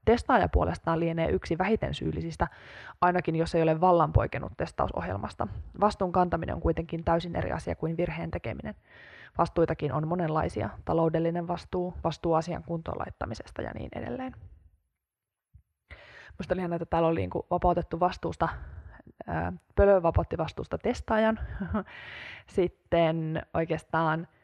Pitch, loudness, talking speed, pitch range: 165 Hz, -29 LUFS, 120 wpm, 105-175 Hz